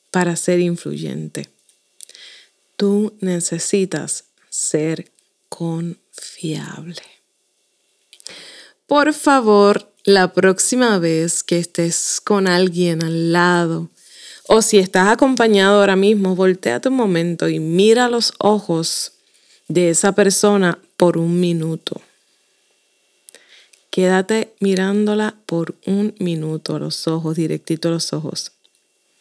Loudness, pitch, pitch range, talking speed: -17 LUFS, 185 Hz, 170-205 Hz, 100 wpm